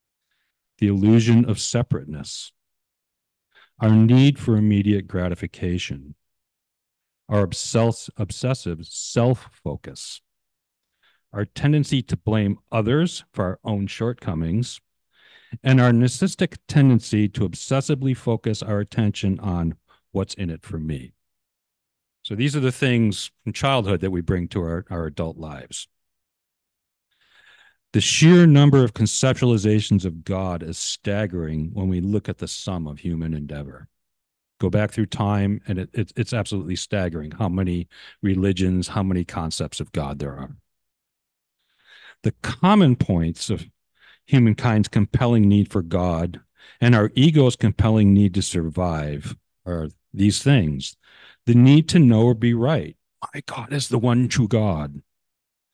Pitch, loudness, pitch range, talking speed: 105 Hz, -21 LUFS, 85-120 Hz, 130 wpm